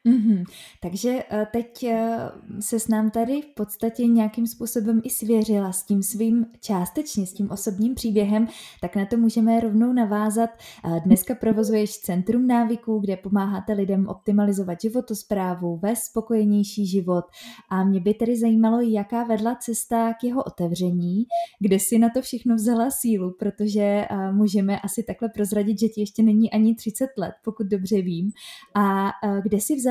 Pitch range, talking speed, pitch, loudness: 200-230 Hz, 155 wpm, 220 Hz, -23 LUFS